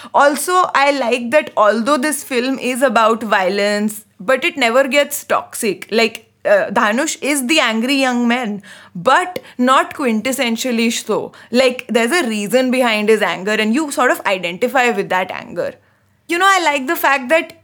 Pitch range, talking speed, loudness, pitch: 225-285 Hz, 165 wpm, -15 LUFS, 250 Hz